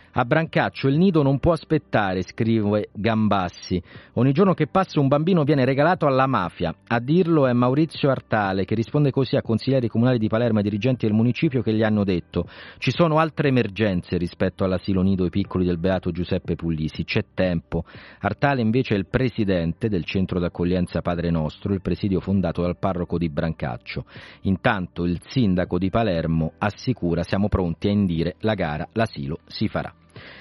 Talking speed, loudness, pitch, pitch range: 170 wpm, -22 LUFS, 105 Hz, 90-130 Hz